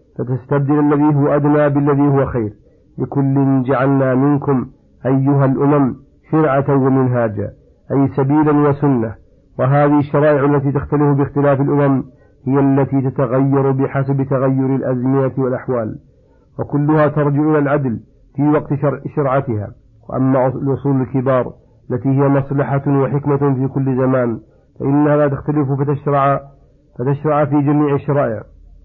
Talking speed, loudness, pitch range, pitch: 115 wpm, -16 LUFS, 130-145 Hz, 140 Hz